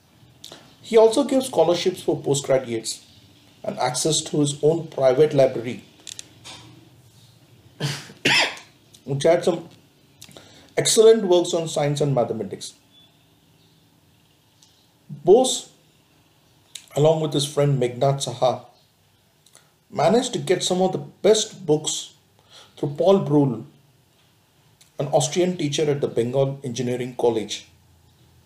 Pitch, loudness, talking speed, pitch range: 145 Hz, -21 LUFS, 100 wpm, 135-165 Hz